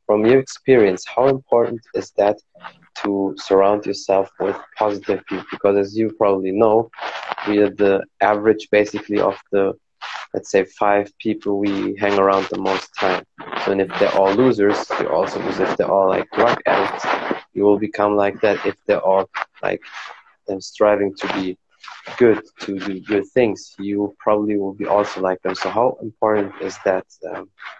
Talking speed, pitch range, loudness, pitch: 175 wpm, 100-105 Hz, -19 LUFS, 100 Hz